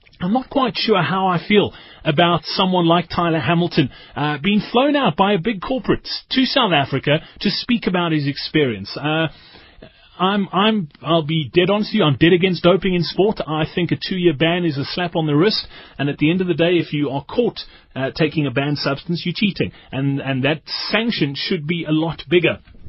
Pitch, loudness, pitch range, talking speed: 170 Hz, -19 LUFS, 150-195 Hz, 215 wpm